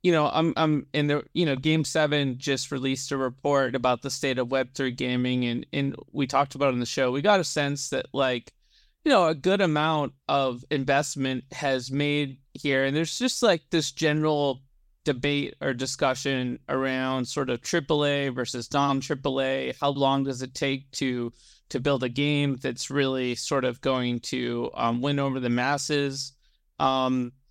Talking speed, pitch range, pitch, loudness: 185 wpm, 130-145 Hz, 135 Hz, -26 LUFS